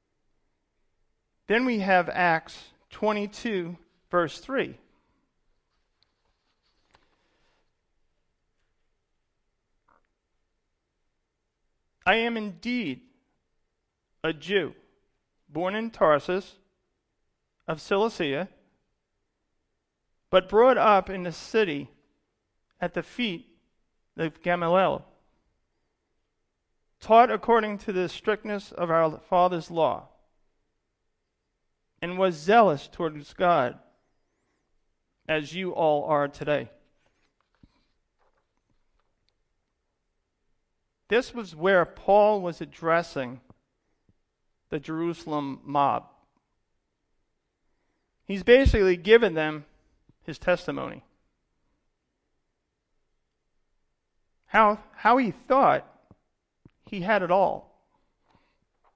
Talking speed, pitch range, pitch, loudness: 70 wpm, 165-215 Hz, 185 Hz, -25 LUFS